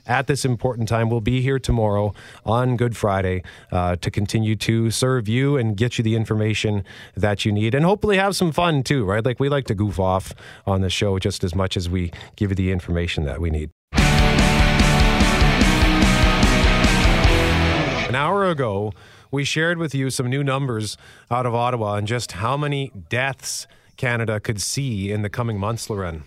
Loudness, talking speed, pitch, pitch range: -20 LUFS, 180 wpm, 110 Hz, 95-125 Hz